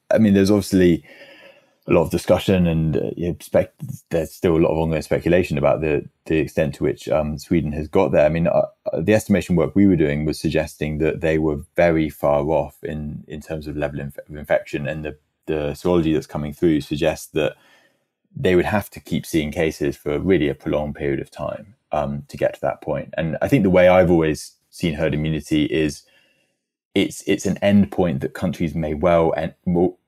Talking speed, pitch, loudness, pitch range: 215 wpm, 80 Hz, -20 LUFS, 75-90 Hz